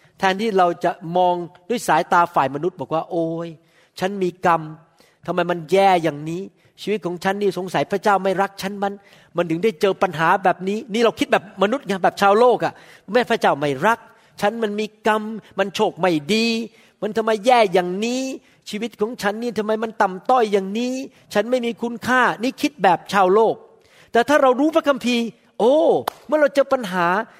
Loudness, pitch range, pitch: -20 LUFS, 175-230 Hz, 200 Hz